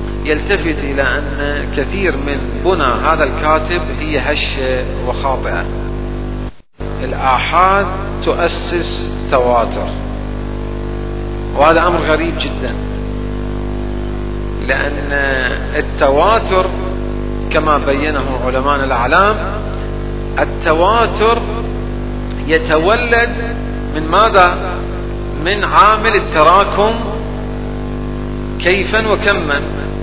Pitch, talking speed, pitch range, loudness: 125 Hz, 65 wpm, 115-140 Hz, -15 LUFS